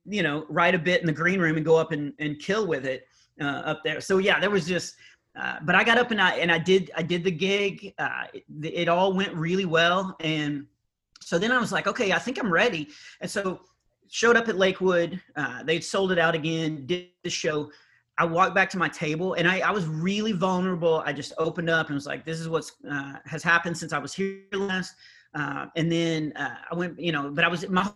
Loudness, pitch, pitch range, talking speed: -25 LUFS, 170 Hz, 160-190 Hz, 245 wpm